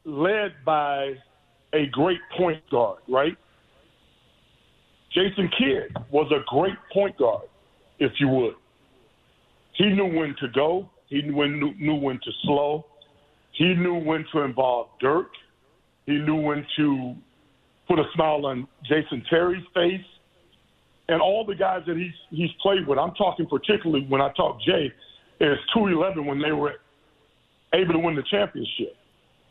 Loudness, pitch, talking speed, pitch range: -24 LUFS, 155 Hz, 150 wpm, 140-180 Hz